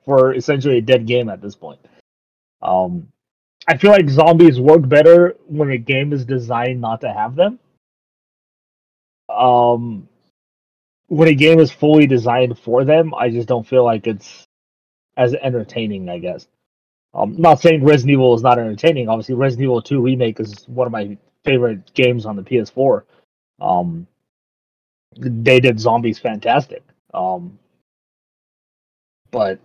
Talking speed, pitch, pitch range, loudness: 150 wpm, 125 Hz, 105-135 Hz, -14 LUFS